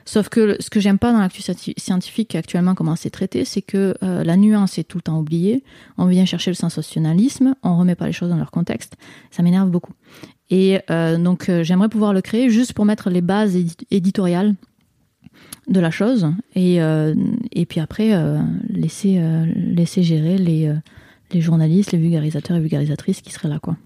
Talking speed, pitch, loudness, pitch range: 195 wpm, 185 Hz, -18 LUFS, 170-205 Hz